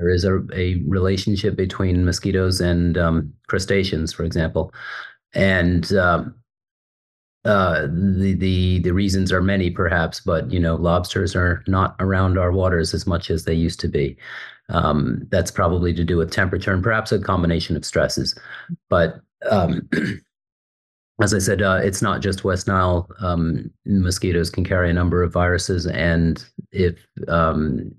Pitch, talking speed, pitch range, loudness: 90 Hz, 155 wpm, 85-95 Hz, -20 LUFS